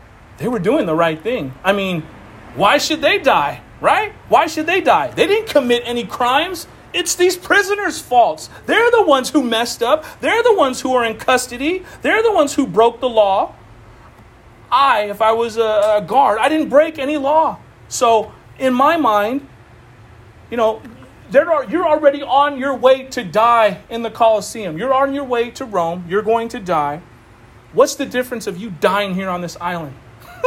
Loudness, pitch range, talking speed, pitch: -16 LUFS, 185-290 Hz, 185 wpm, 235 Hz